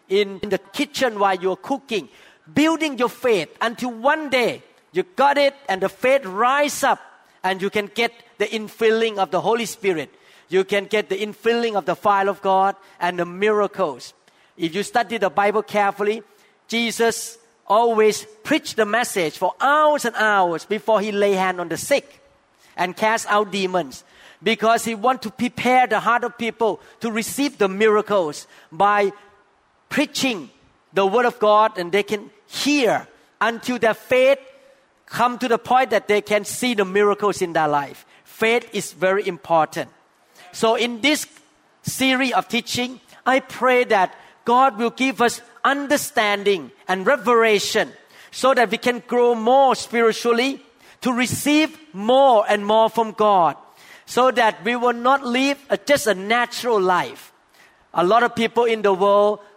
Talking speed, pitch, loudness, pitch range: 160 wpm, 225 Hz, -20 LUFS, 200-245 Hz